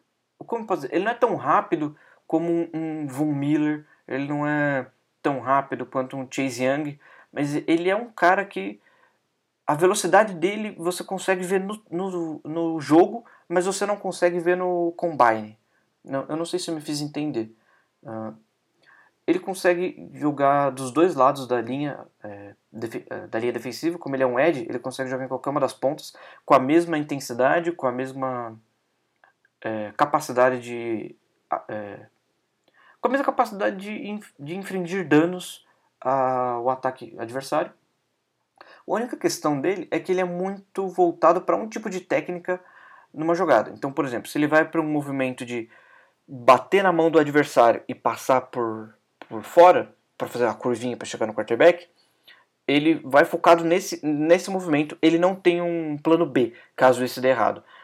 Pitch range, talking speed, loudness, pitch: 130-175 Hz, 170 wpm, -23 LUFS, 150 Hz